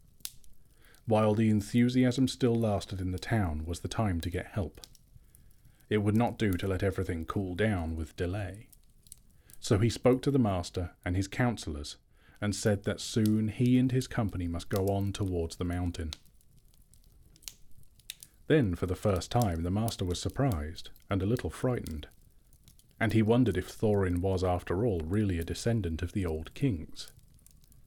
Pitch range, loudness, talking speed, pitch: 90-115 Hz, -31 LUFS, 165 wpm, 100 Hz